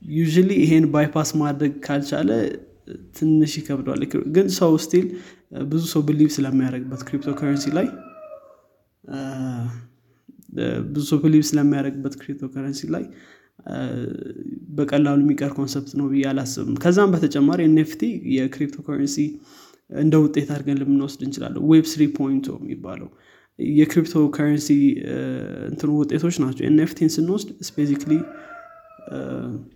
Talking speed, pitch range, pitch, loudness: 85 wpm, 140-155 Hz, 150 Hz, -21 LUFS